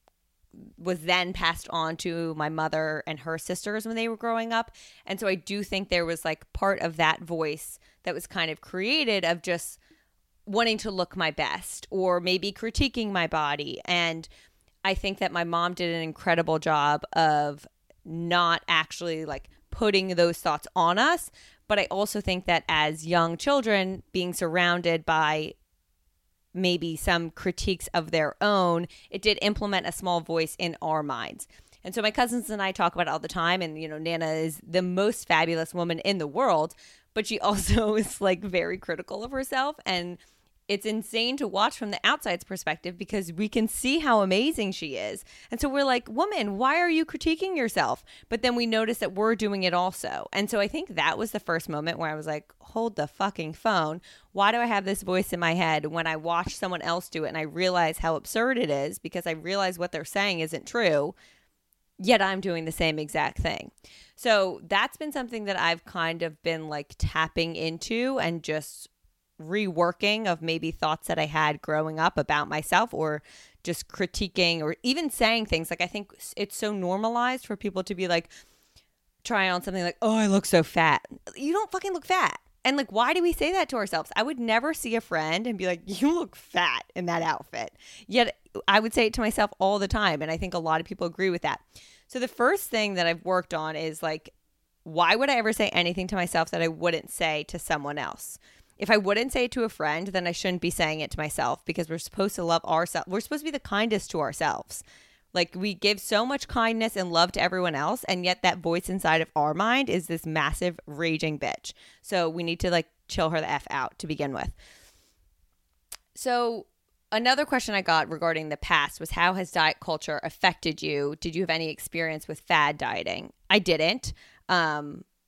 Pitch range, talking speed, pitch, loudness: 160-210 Hz, 205 wpm, 180 Hz, -27 LUFS